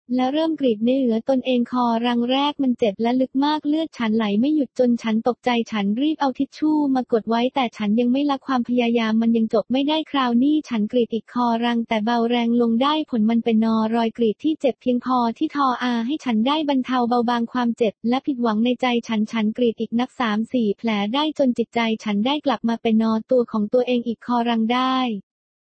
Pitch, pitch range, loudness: 245 Hz, 230-260 Hz, -21 LUFS